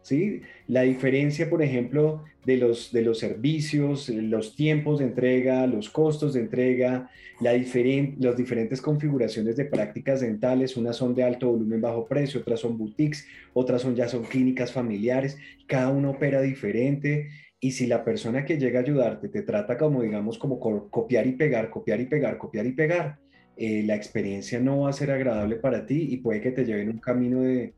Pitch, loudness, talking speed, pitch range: 125 Hz, -26 LUFS, 190 wpm, 120-140 Hz